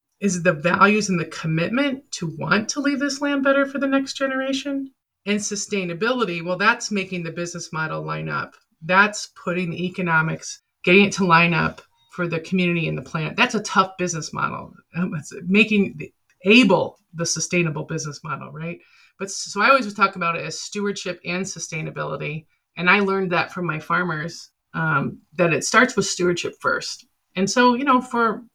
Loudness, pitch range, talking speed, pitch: -21 LUFS, 170-225 Hz, 185 wpm, 190 Hz